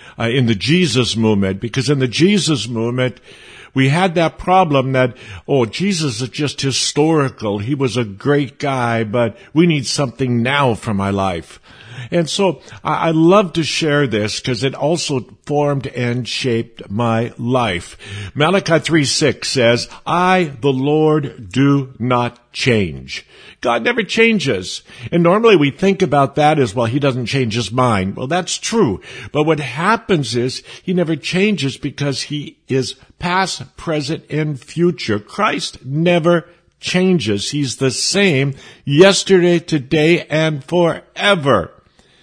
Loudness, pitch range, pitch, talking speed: -16 LUFS, 120-165 Hz, 140 Hz, 140 wpm